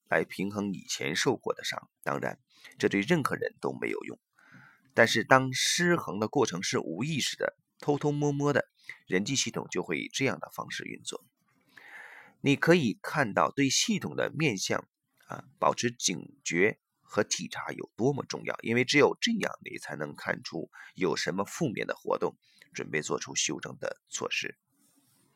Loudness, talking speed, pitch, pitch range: -30 LUFS, 245 characters per minute, 140 Hz, 115-170 Hz